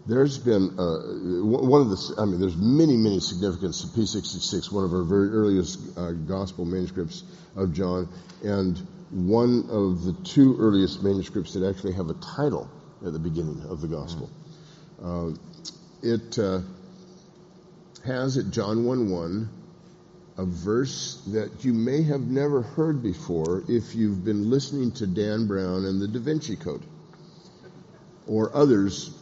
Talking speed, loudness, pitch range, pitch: 150 wpm, -25 LUFS, 95-155 Hz, 110 Hz